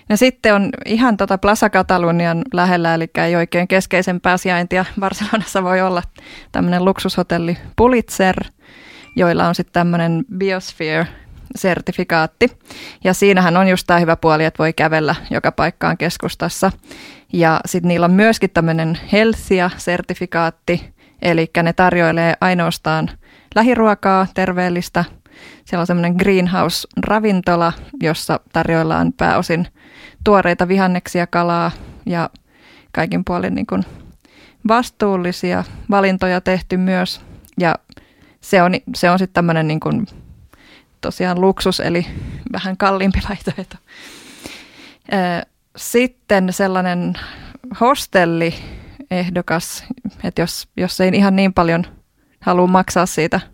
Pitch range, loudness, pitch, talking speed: 170-195 Hz, -16 LUFS, 185 Hz, 110 wpm